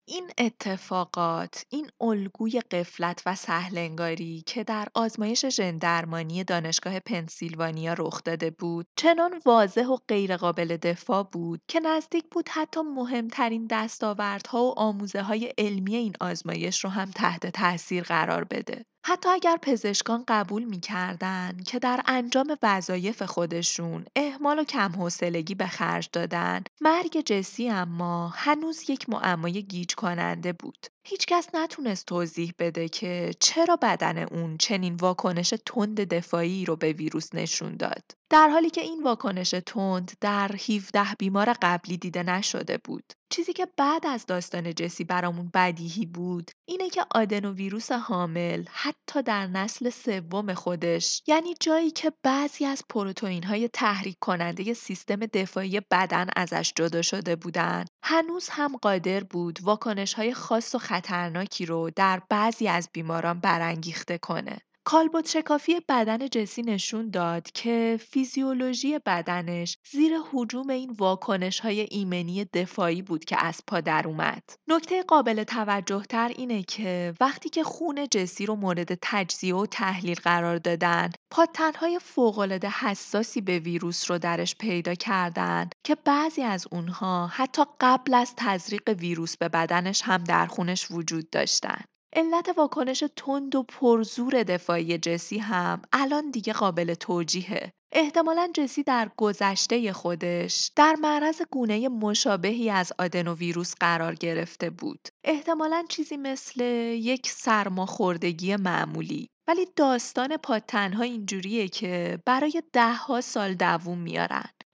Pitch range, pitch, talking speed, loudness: 175-255 Hz, 205 Hz, 135 wpm, -27 LUFS